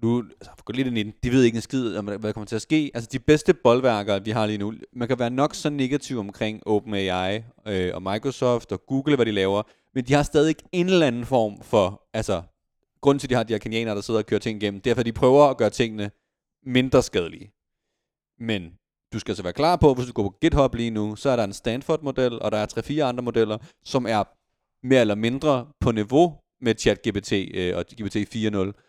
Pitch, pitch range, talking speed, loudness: 115 Hz, 105-130 Hz, 230 wpm, -23 LUFS